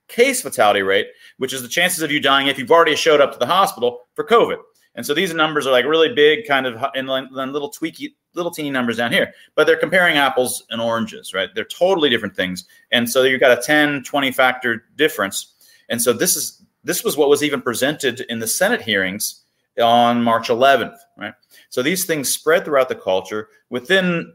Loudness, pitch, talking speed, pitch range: -17 LUFS, 140 Hz, 210 wpm, 120-175 Hz